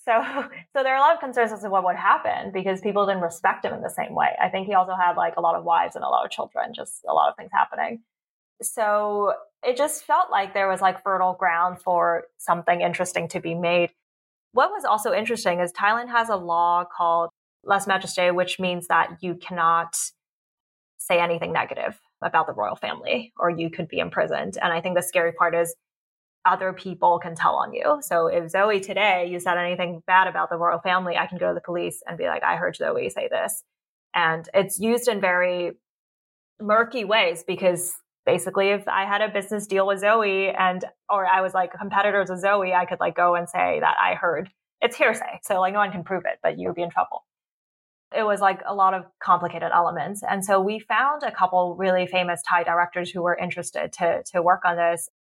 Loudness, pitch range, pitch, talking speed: -23 LUFS, 175-200 Hz, 185 Hz, 220 wpm